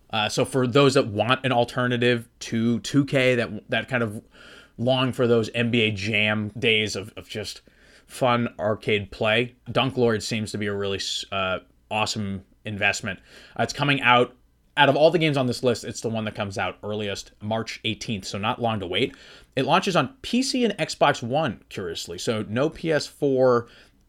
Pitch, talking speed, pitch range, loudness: 120 Hz, 180 wpm, 105-130 Hz, -24 LUFS